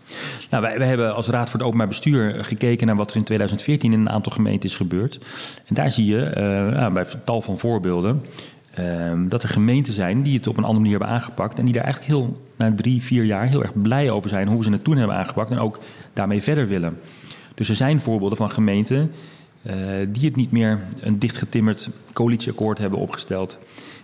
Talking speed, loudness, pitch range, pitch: 215 wpm, -21 LUFS, 105-130 Hz, 110 Hz